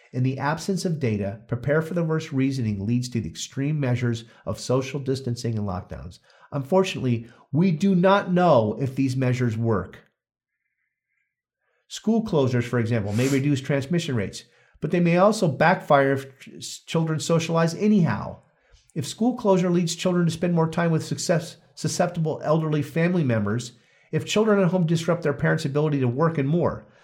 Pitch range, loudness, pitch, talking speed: 125-170 Hz, -23 LUFS, 145 Hz, 160 wpm